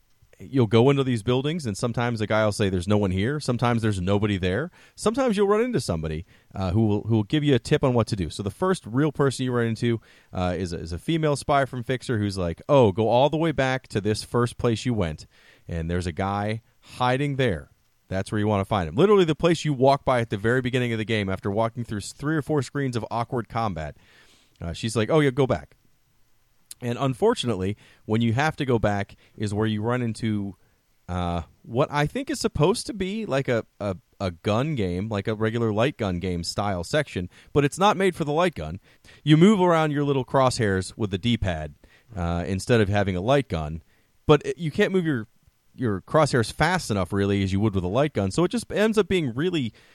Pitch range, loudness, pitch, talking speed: 100-145 Hz, -24 LUFS, 115 Hz, 235 wpm